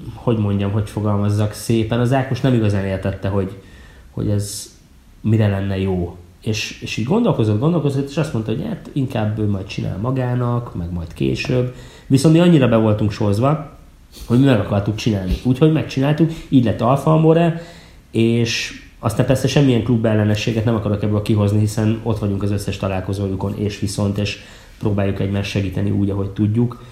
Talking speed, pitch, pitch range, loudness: 165 wpm, 105 Hz, 100-125 Hz, -18 LUFS